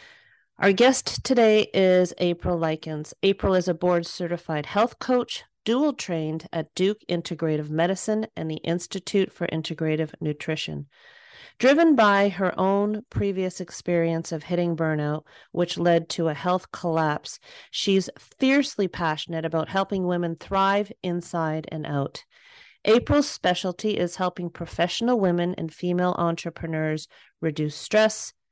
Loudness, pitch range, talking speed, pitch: -24 LUFS, 165-200 Hz, 130 wpm, 175 Hz